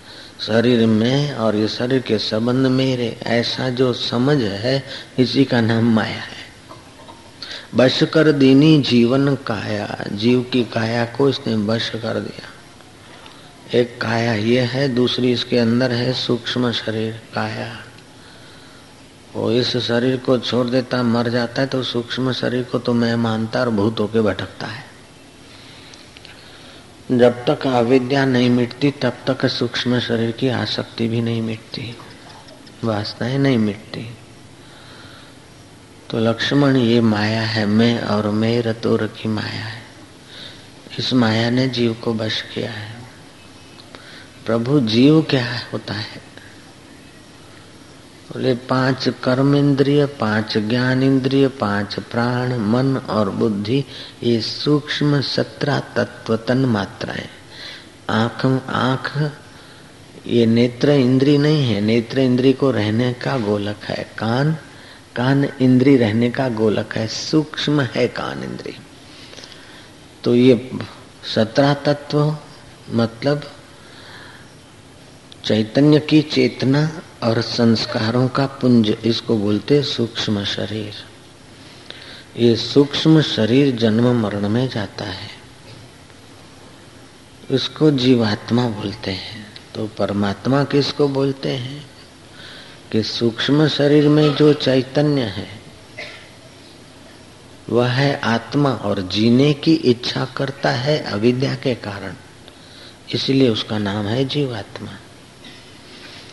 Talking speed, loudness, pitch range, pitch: 115 wpm, -18 LUFS, 115-135 Hz, 120 Hz